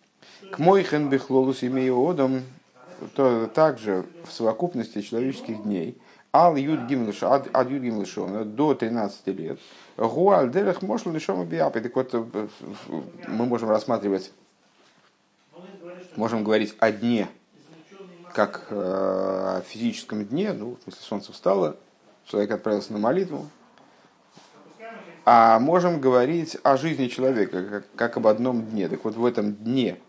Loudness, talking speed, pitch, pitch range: -24 LUFS, 110 wpm, 125 Hz, 110-155 Hz